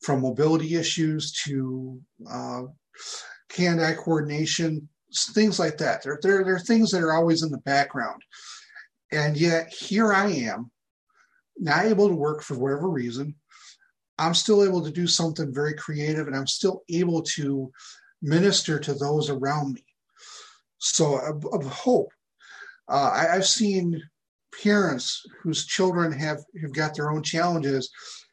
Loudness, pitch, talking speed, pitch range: -24 LUFS, 160 Hz, 145 wpm, 145-185 Hz